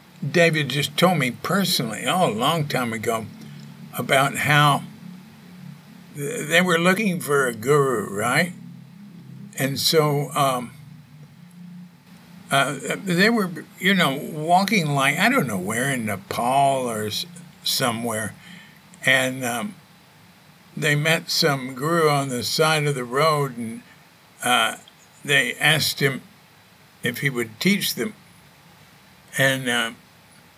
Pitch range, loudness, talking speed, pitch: 140-180 Hz, -21 LUFS, 120 wpm, 165 Hz